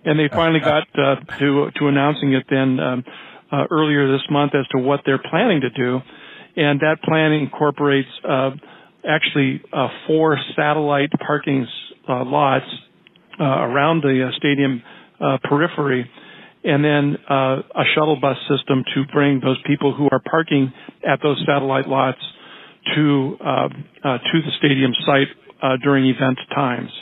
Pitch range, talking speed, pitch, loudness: 135-150 Hz, 155 wpm, 140 Hz, -18 LUFS